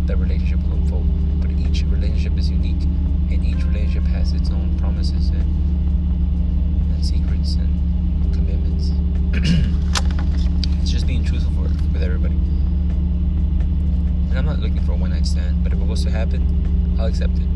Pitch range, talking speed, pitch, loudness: 75-80 Hz, 155 wpm, 80 Hz, -20 LUFS